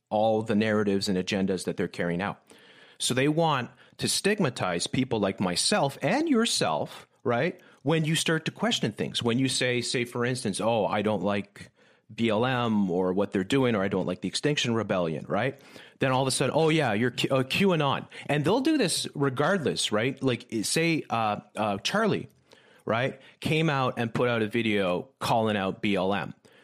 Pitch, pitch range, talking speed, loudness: 125 Hz, 105-150 Hz, 185 wpm, -27 LUFS